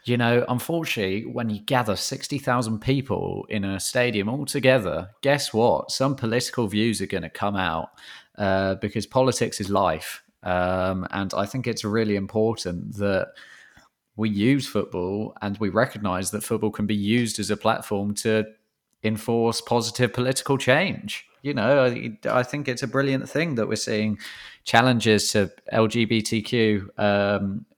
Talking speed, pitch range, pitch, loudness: 155 wpm, 100-125 Hz, 110 Hz, -24 LUFS